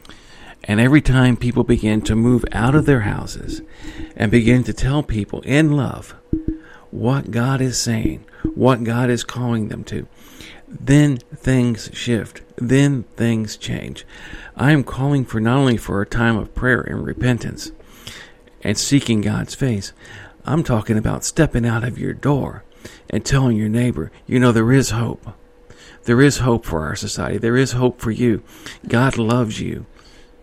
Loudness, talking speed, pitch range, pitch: -18 LUFS, 160 wpm, 110-130 Hz, 120 Hz